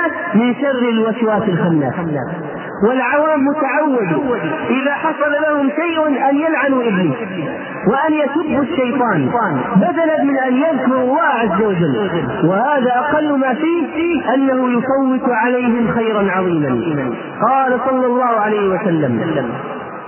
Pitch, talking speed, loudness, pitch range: 255 Hz, 110 wpm, -16 LUFS, 210-290 Hz